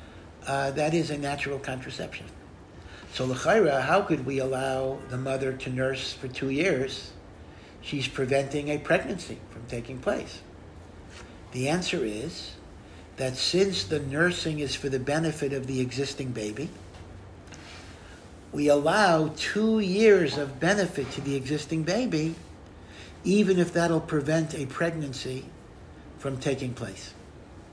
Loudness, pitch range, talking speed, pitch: -27 LUFS, 100-150 Hz, 130 wpm, 135 Hz